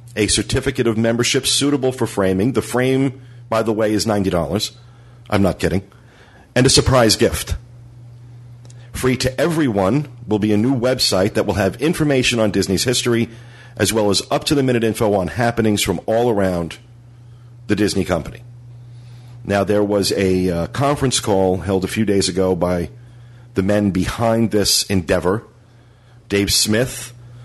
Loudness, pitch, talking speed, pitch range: -17 LUFS, 115 Hz, 155 wpm, 100-120 Hz